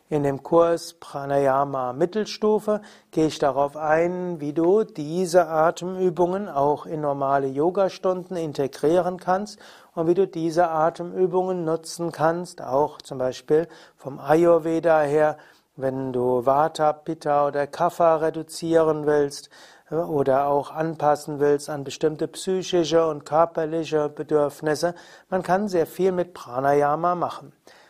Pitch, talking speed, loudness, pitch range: 160 Hz, 125 wpm, -23 LUFS, 145-175 Hz